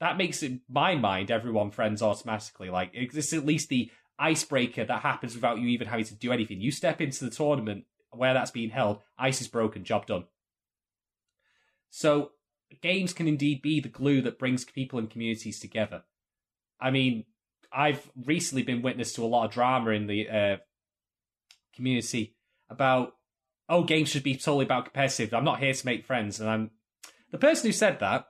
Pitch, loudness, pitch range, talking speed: 125 Hz, -28 LUFS, 110-145 Hz, 185 wpm